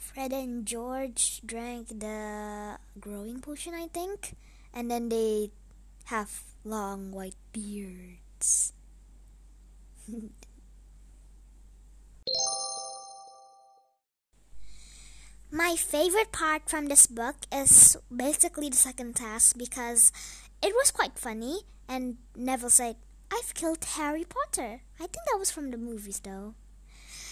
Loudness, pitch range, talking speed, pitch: -25 LUFS, 205-285 Hz, 105 wpm, 235 Hz